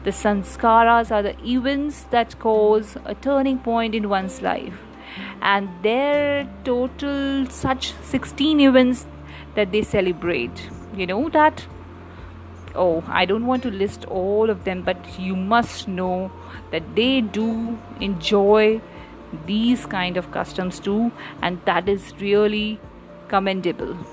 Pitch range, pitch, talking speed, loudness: 185-240 Hz, 210 Hz, 130 wpm, -21 LUFS